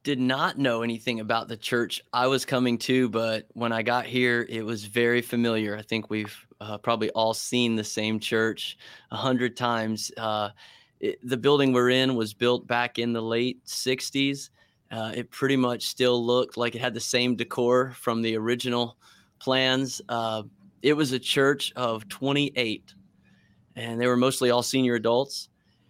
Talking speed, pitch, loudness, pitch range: 175 wpm, 120 Hz, -26 LUFS, 115-130 Hz